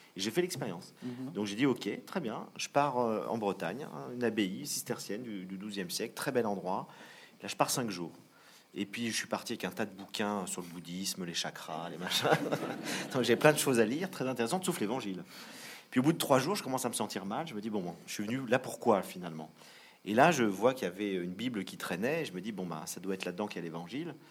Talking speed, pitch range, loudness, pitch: 255 wpm, 95-125 Hz, -34 LUFS, 105 Hz